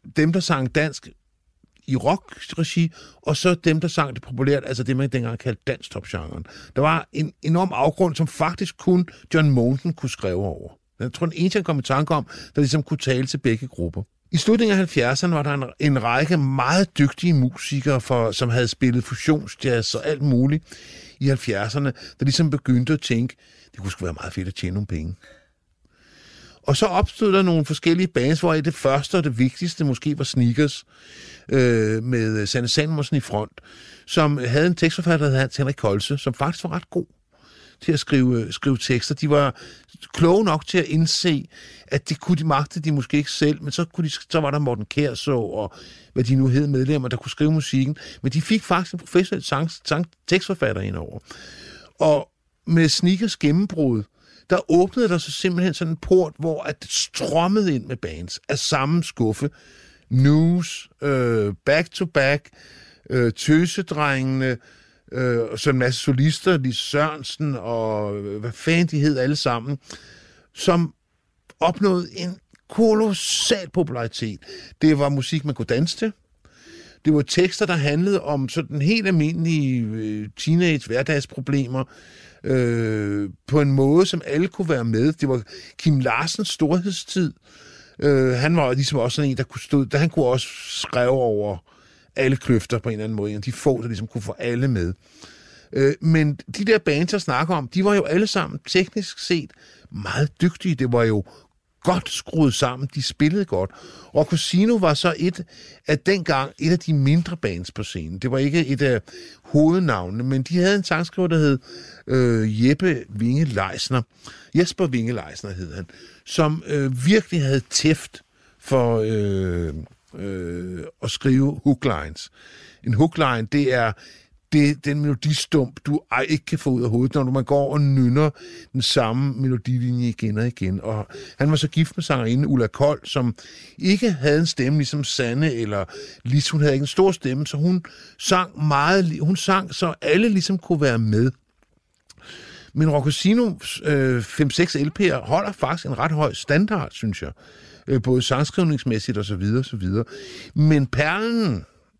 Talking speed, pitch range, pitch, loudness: 175 wpm, 125-165 Hz, 145 Hz, -21 LUFS